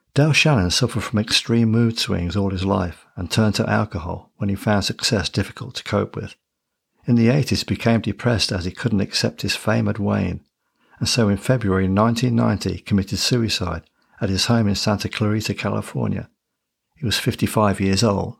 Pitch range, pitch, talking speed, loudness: 100-115 Hz, 105 Hz, 180 wpm, -20 LUFS